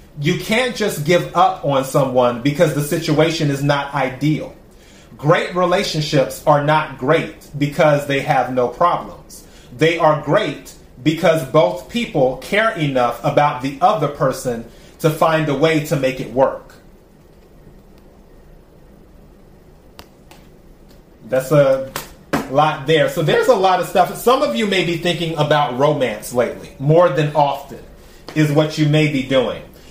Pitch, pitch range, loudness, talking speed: 155 Hz, 140-170 Hz, -17 LUFS, 140 wpm